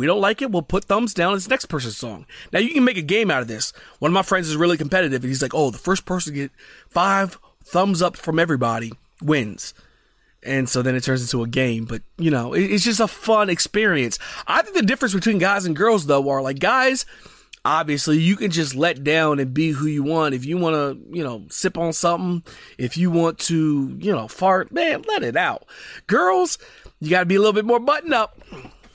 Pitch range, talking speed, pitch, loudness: 140-200 Hz, 235 wpm, 170 Hz, -20 LUFS